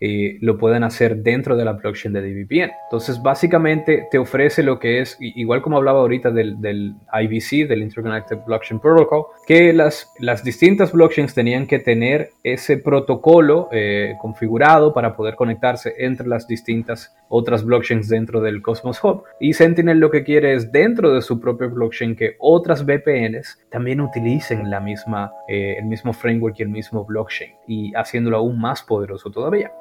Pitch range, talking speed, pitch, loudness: 110-145 Hz, 170 wpm, 120 Hz, -17 LUFS